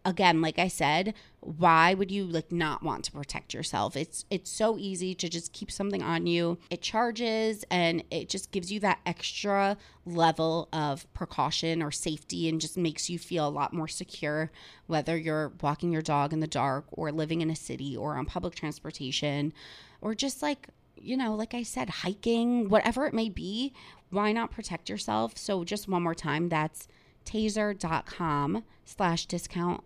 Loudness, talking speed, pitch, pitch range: -30 LUFS, 180 wpm, 170 Hz, 155-200 Hz